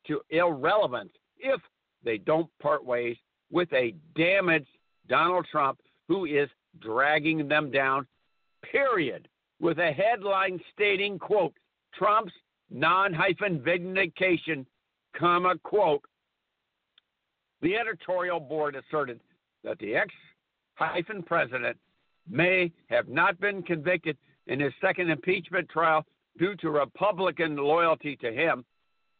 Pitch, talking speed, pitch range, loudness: 170 Hz, 110 wpm, 150-185 Hz, -27 LUFS